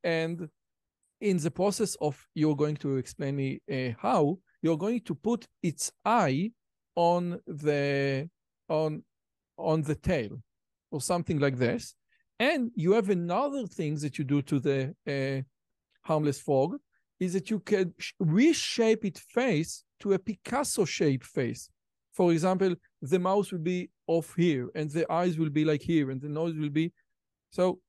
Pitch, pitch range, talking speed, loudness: 165 Hz, 145-190 Hz, 160 wpm, -29 LUFS